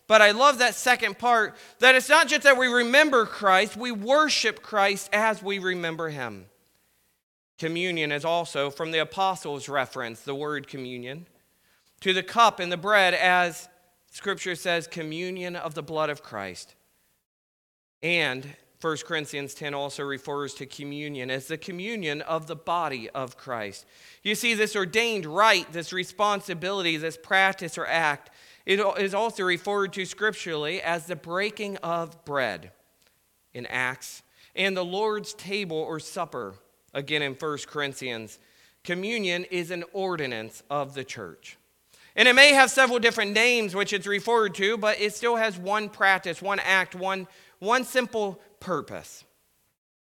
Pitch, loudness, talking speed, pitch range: 180 Hz, -24 LUFS, 150 wpm, 150-210 Hz